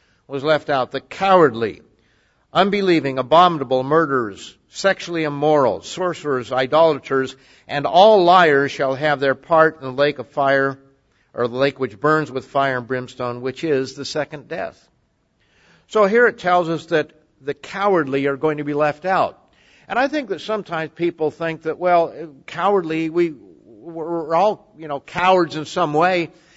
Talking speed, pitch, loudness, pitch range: 160 wpm, 155 Hz, -19 LUFS, 135-170 Hz